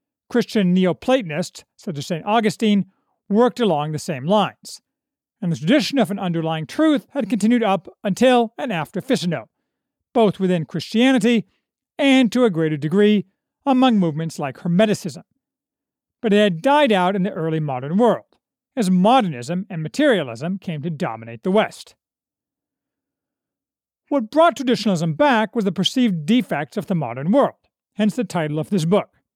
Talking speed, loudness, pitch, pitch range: 150 wpm, -19 LUFS, 205 Hz, 175-245 Hz